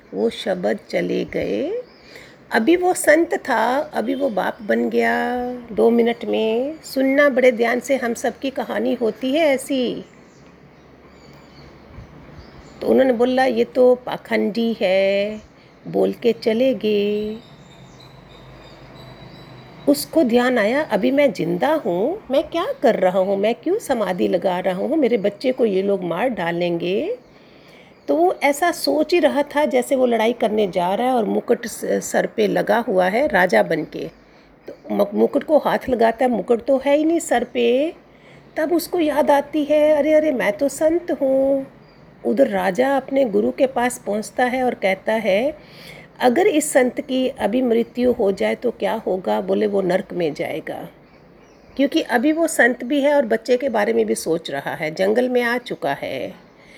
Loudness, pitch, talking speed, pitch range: -19 LUFS, 245 Hz, 165 wpm, 210-280 Hz